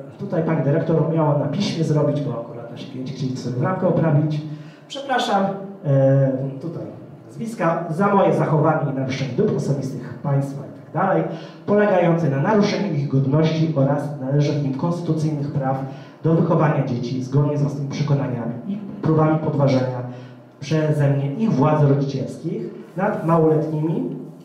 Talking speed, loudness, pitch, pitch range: 135 wpm, -20 LUFS, 150 Hz, 135-165 Hz